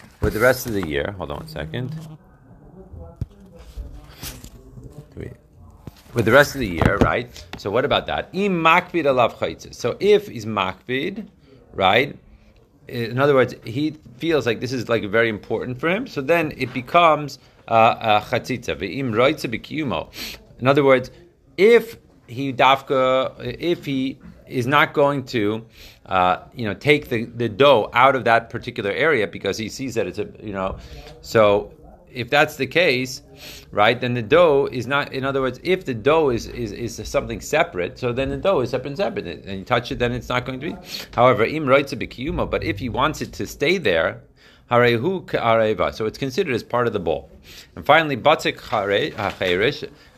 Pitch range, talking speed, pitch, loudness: 115-145 Hz, 165 wpm, 130 Hz, -20 LUFS